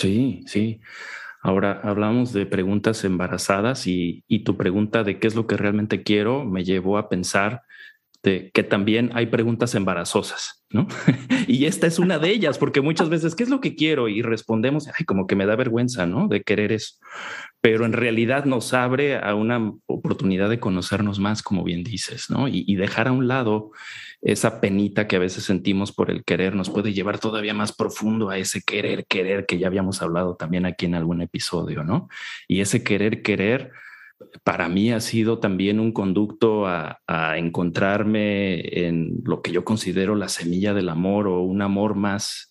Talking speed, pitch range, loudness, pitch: 185 wpm, 95-115 Hz, -22 LUFS, 105 Hz